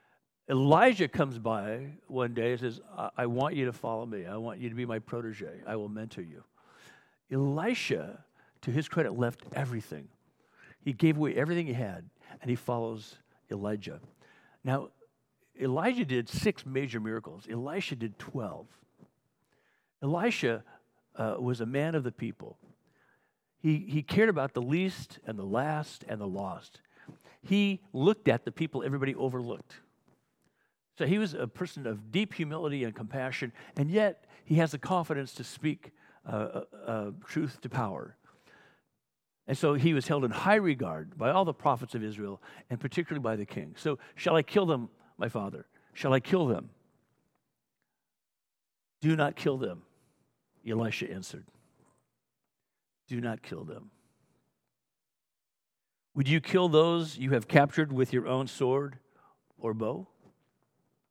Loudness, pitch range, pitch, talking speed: -31 LUFS, 120-160 Hz, 135 Hz, 150 wpm